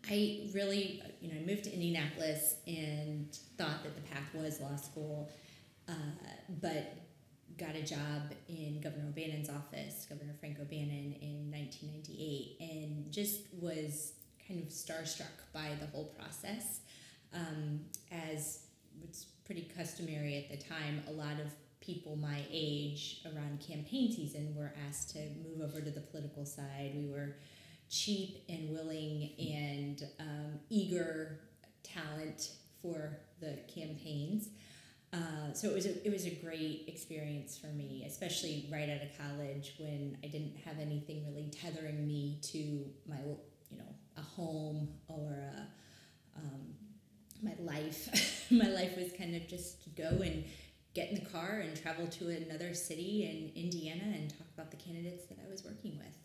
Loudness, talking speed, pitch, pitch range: -42 LUFS, 150 wpm, 155 Hz, 150-170 Hz